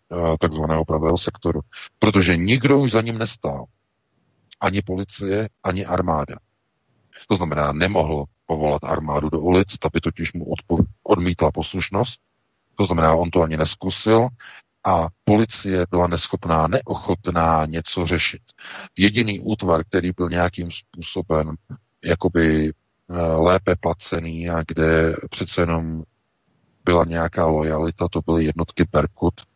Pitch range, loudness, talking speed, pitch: 80-95 Hz, -21 LUFS, 120 wpm, 85 Hz